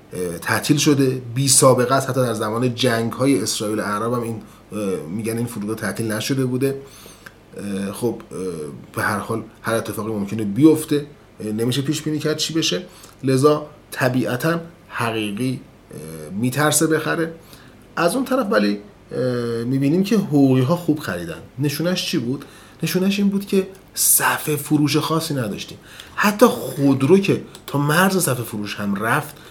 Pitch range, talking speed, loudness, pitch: 115-155 Hz, 140 wpm, -20 LUFS, 135 Hz